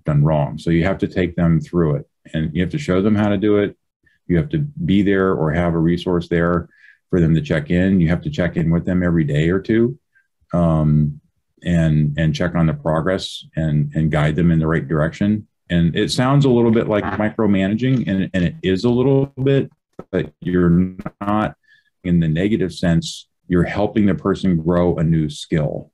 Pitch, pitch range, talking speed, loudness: 90 Hz, 80-105 Hz, 210 wpm, -18 LUFS